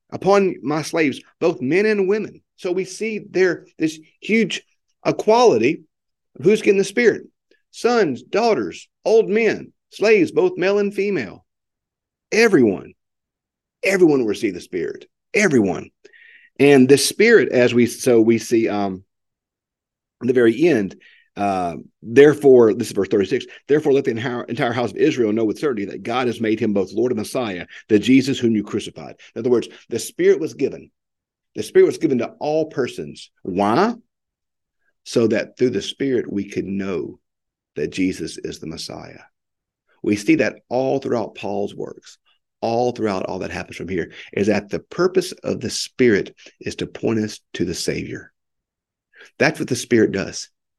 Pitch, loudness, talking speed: 150 Hz, -19 LUFS, 165 wpm